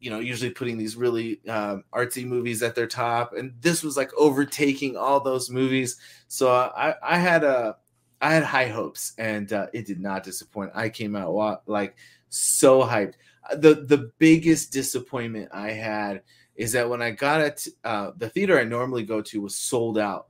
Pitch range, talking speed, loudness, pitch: 110-135 Hz, 185 wpm, -24 LUFS, 120 Hz